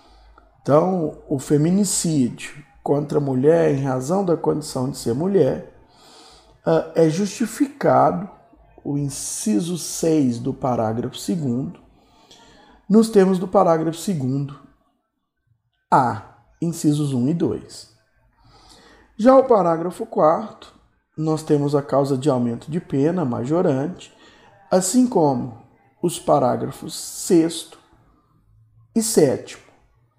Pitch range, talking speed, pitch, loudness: 135-180 Hz, 100 wpm, 155 Hz, -20 LUFS